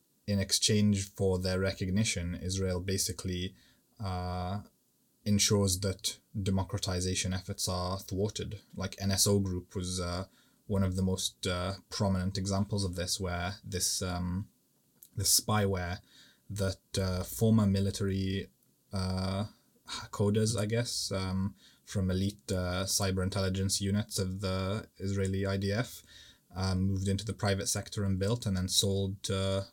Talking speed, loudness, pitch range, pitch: 130 wpm, -32 LUFS, 95-100 Hz, 95 Hz